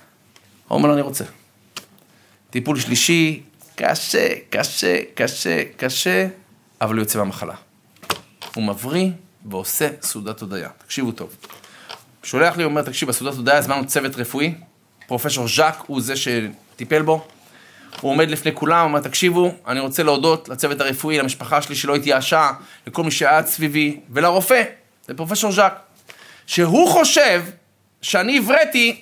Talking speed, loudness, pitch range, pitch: 135 wpm, -18 LUFS, 125-170 Hz, 150 Hz